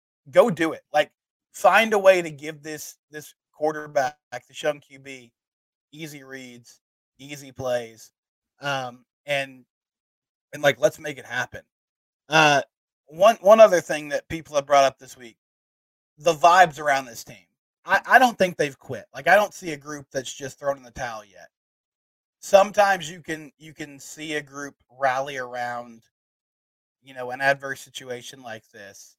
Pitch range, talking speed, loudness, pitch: 125-160 Hz, 165 wpm, -21 LUFS, 140 Hz